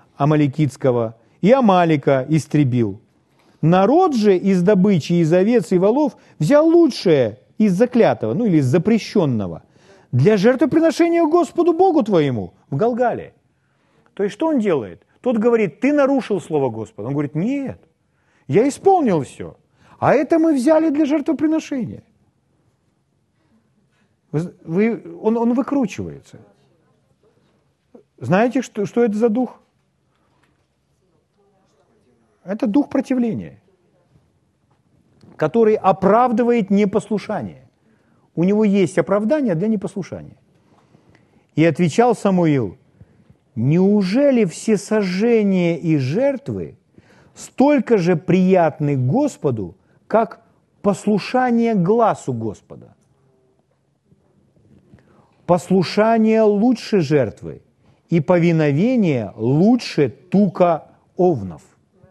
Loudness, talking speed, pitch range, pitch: -17 LUFS, 95 wpm, 155-240 Hz, 200 Hz